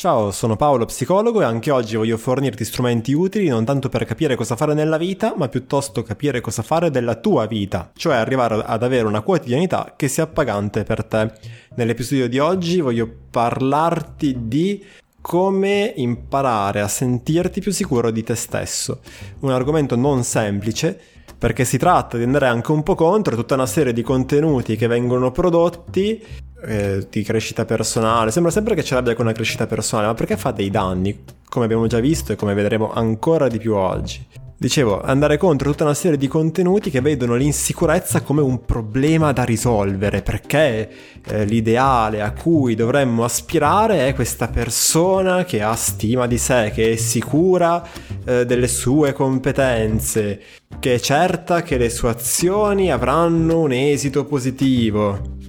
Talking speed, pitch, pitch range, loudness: 165 wpm, 125 Hz, 115-155 Hz, -18 LUFS